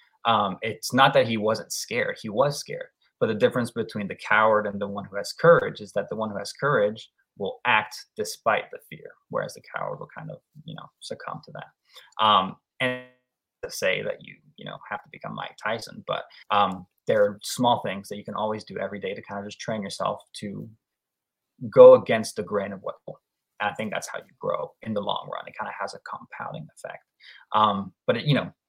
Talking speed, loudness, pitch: 225 wpm, -24 LUFS, 125 Hz